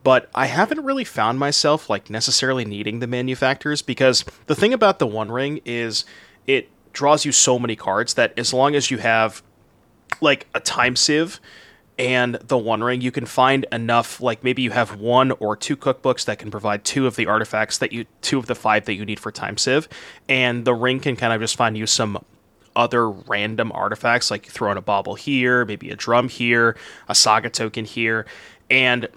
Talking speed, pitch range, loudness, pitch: 200 wpm, 110-130 Hz, -20 LUFS, 125 Hz